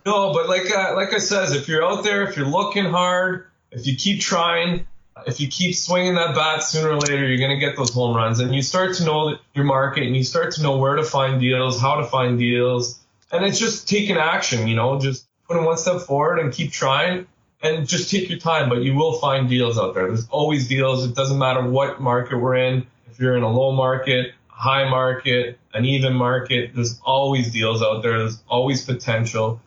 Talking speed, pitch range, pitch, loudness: 220 wpm, 125-165 Hz, 135 Hz, -20 LUFS